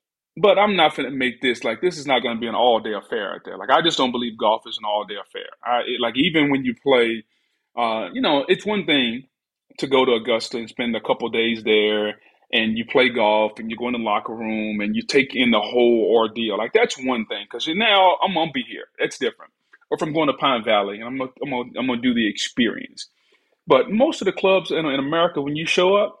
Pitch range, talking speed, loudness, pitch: 115-185 Hz, 265 wpm, -20 LUFS, 130 Hz